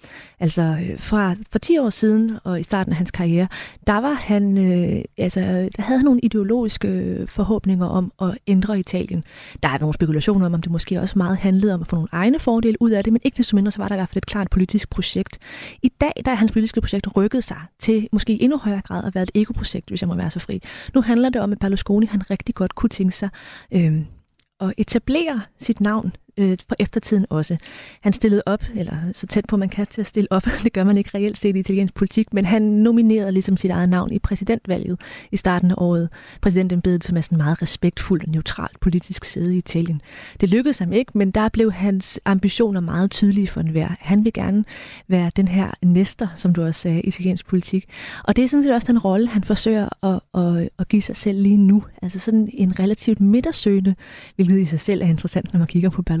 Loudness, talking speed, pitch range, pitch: -20 LUFS, 225 wpm, 180-215 Hz, 195 Hz